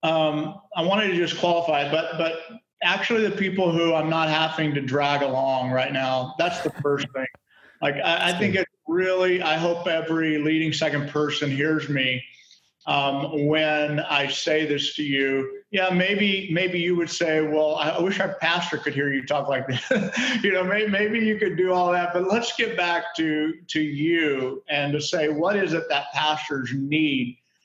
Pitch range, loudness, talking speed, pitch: 145-180 Hz, -23 LUFS, 190 wpm, 160 Hz